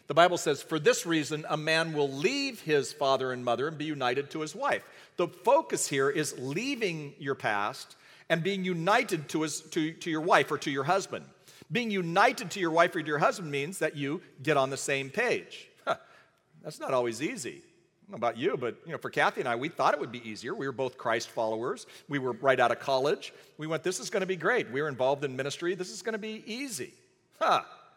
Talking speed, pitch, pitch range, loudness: 240 wpm, 155 Hz, 140-180 Hz, -30 LUFS